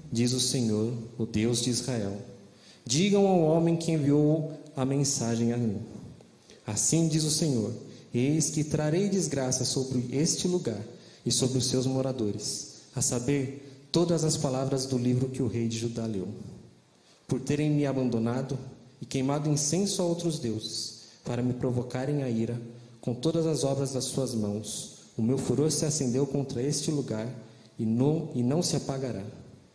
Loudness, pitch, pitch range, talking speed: -28 LUFS, 130 Hz, 115-150 Hz, 165 wpm